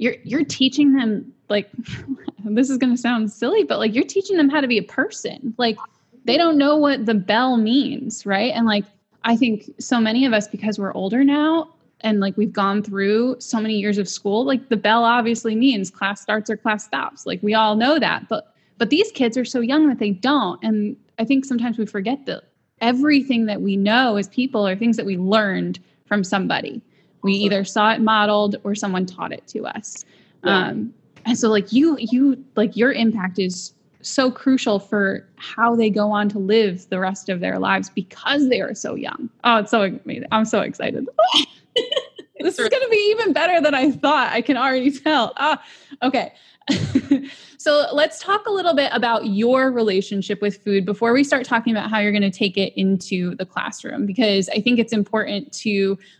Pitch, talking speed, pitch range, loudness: 230 Hz, 205 wpm, 205-270 Hz, -20 LUFS